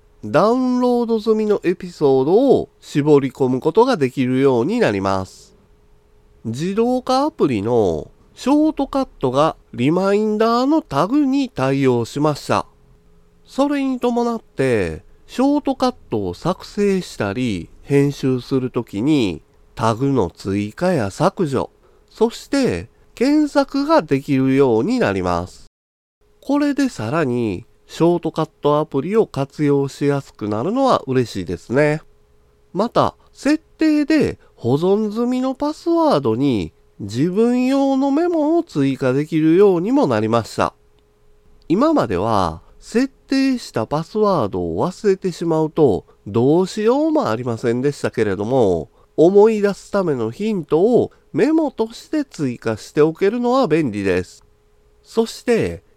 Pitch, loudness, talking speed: 155 Hz, -18 LUFS, 270 characters per minute